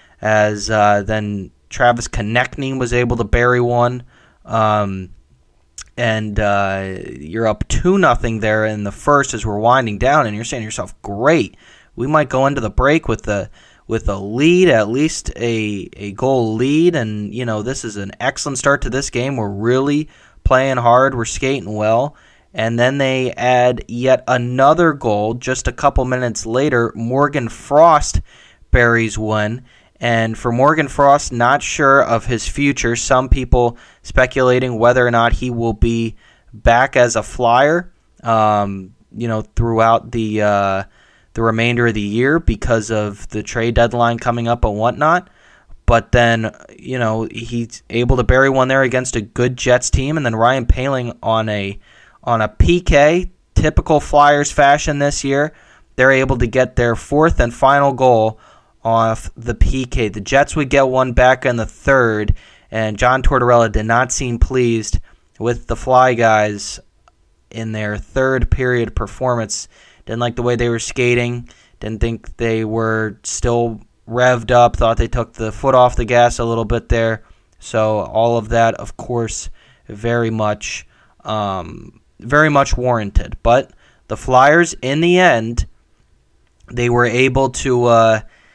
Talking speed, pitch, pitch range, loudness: 160 wpm, 120 Hz, 110-130 Hz, -16 LUFS